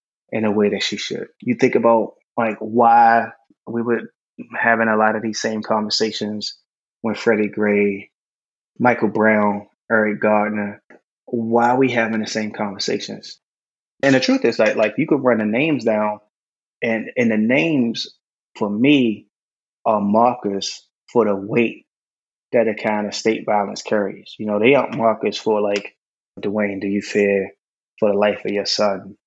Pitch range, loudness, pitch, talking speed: 105-115 Hz, -19 LUFS, 110 Hz, 165 wpm